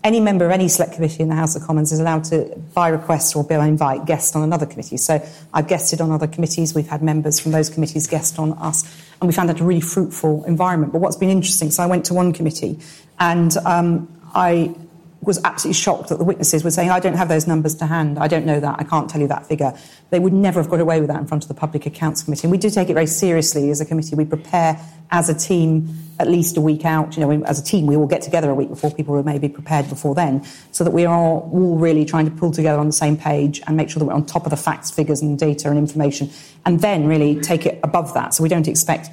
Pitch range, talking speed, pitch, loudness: 150-170 Hz, 270 wpm, 160 Hz, -18 LUFS